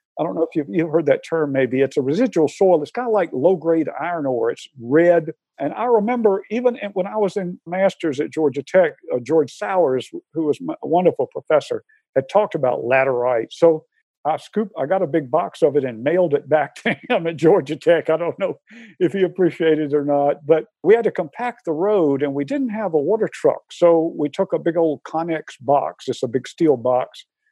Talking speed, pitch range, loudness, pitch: 225 wpm, 150-210 Hz, -20 LUFS, 165 Hz